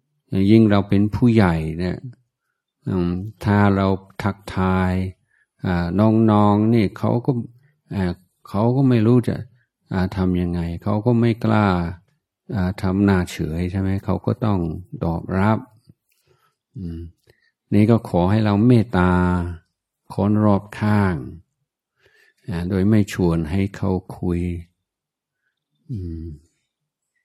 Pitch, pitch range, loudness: 100 Hz, 90-110 Hz, -20 LUFS